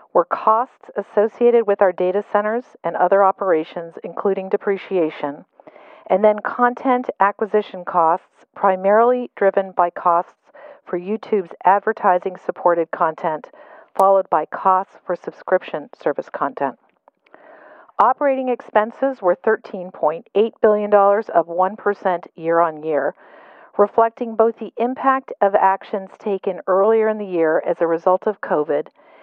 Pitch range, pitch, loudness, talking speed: 185-225 Hz, 200 Hz, -19 LUFS, 120 wpm